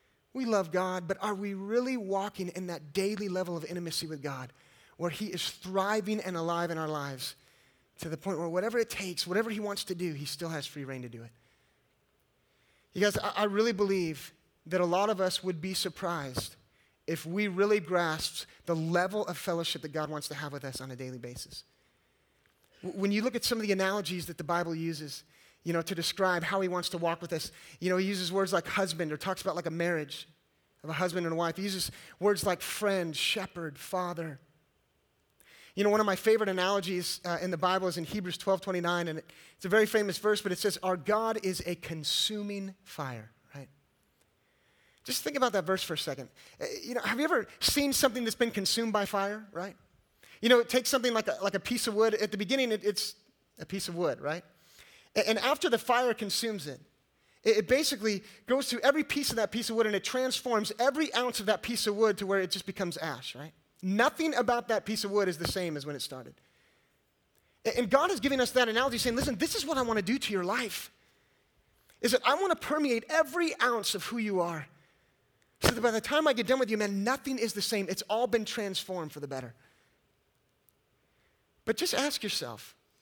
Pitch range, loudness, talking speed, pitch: 170-225 Hz, -31 LUFS, 220 wpm, 195 Hz